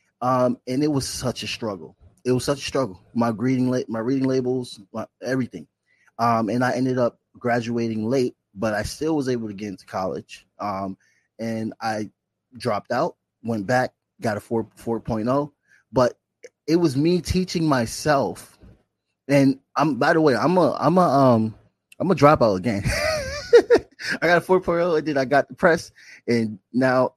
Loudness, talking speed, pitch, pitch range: -22 LUFS, 175 wpm, 125 Hz, 110-140 Hz